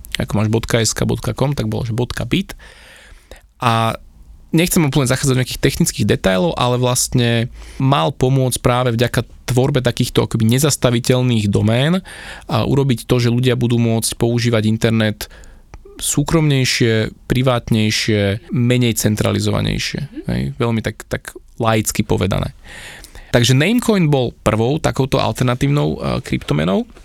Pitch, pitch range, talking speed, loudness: 120 Hz, 110-130 Hz, 115 wpm, -17 LUFS